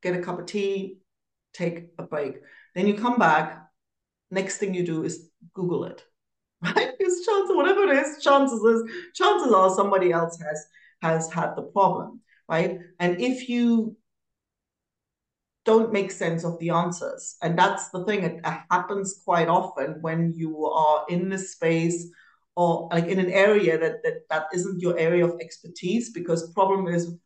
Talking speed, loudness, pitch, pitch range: 165 wpm, -24 LUFS, 185 Hz, 170-215 Hz